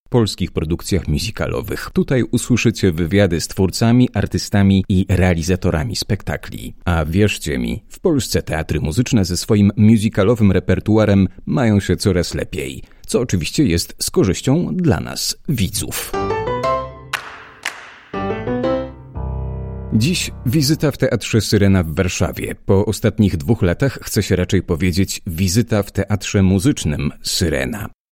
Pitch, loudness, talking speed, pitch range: 100 Hz, -18 LUFS, 115 wpm, 90-115 Hz